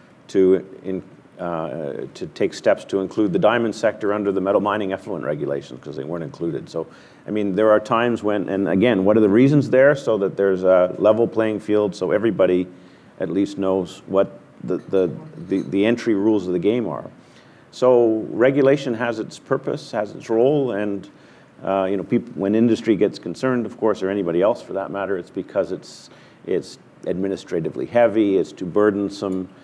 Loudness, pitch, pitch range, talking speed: -20 LUFS, 100 Hz, 95-110 Hz, 185 wpm